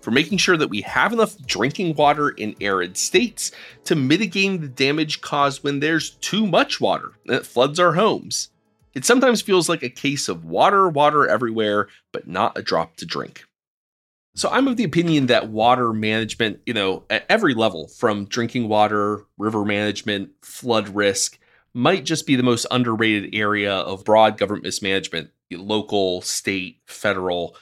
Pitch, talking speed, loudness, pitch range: 120 Hz, 165 wpm, -20 LUFS, 105-150 Hz